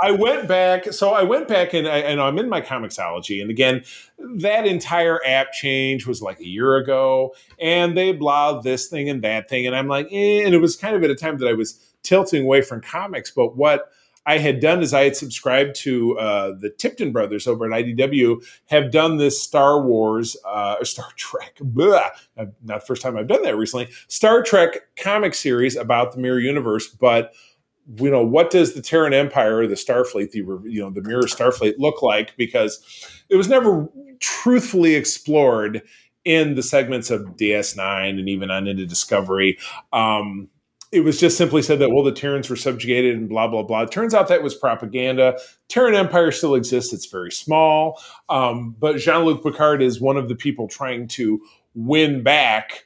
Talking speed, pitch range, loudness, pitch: 195 wpm, 115-160 Hz, -19 LUFS, 135 Hz